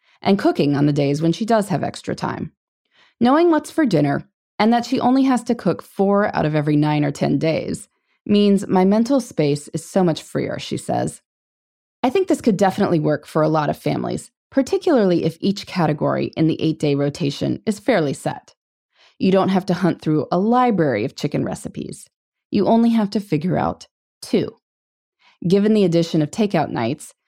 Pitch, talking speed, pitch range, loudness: 185 Hz, 190 wpm, 155-225 Hz, -19 LUFS